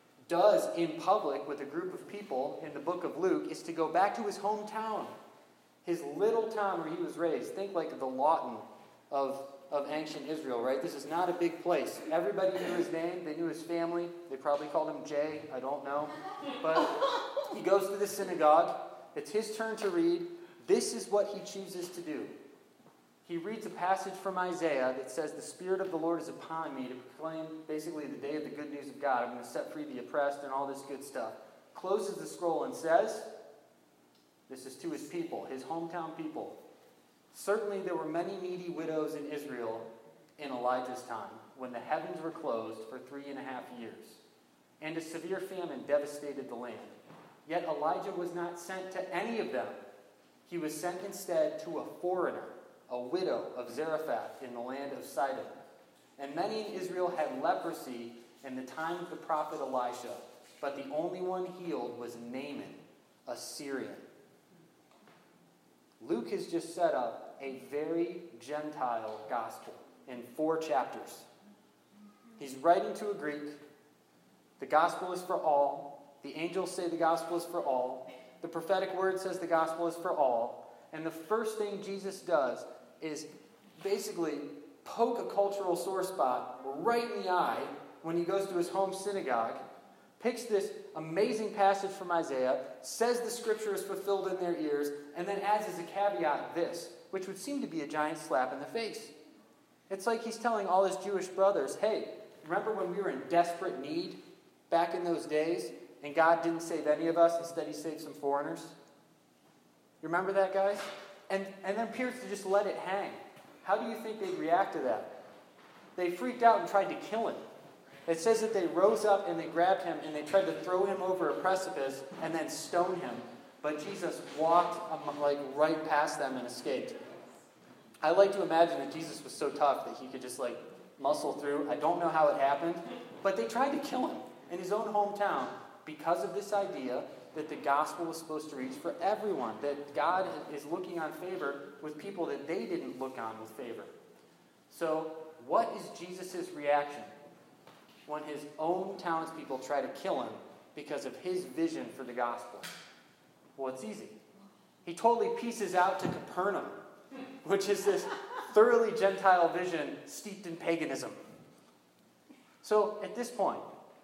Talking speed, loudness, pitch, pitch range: 180 wpm, -34 LUFS, 170 Hz, 145-195 Hz